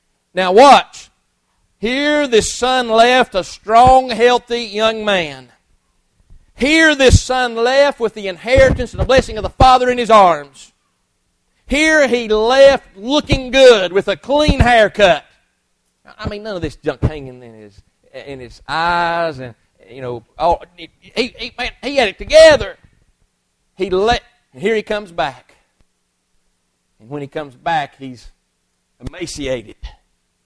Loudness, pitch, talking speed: -13 LUFS, 195 Hz, 145 wpm